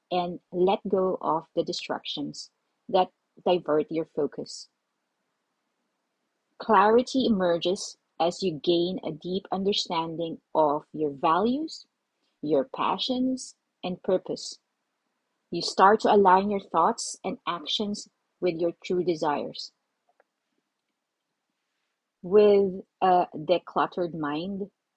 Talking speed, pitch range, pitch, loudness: 100 wpm, 165-200 Hz, 180 Hz, -26 LUFS